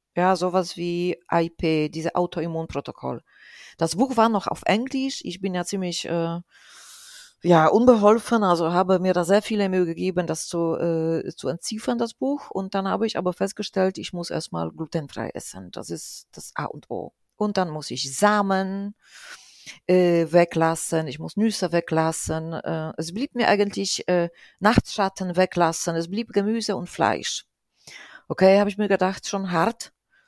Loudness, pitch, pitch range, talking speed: -23 LUFS, 180 Hz, 165-205 Hz, 160 wpm